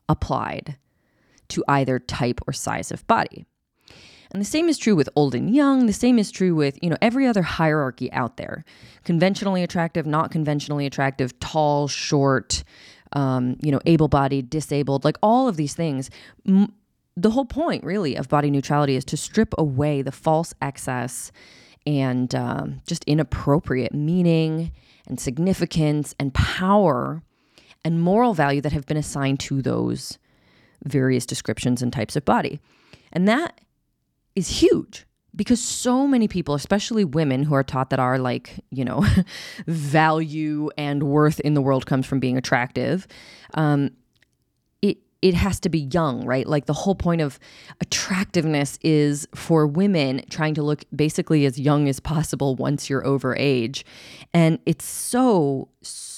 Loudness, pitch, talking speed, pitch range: -22 LUFS, 150 Hz, 155 wpm, 135-175 Hz